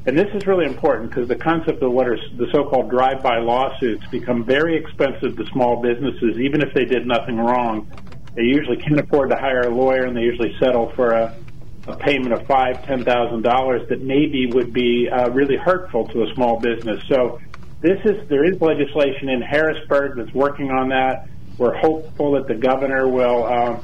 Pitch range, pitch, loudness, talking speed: 120-140 Hz, 130 Hz, -19 LUFS, 195 wpm